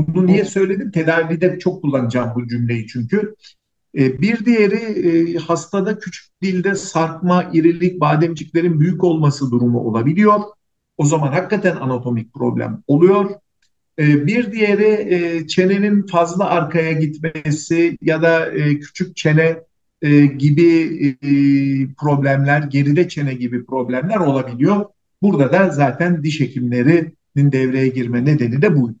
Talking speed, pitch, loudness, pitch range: 110 wpm, 160 Hz, -16 LUFS, 140-180 Hz